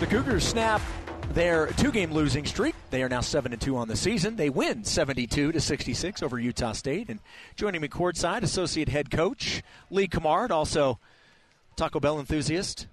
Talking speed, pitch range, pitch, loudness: 160 wpm, 130-170 Hz, 150 Hz, -27 LUFS